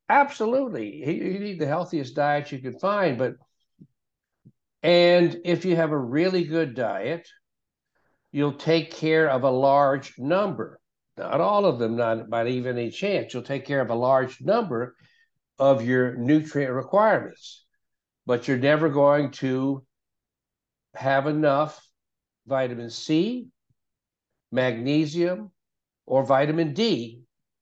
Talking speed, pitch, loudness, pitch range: 125 wpm, 145 Hz, -24 LUFS, 130-170 Hz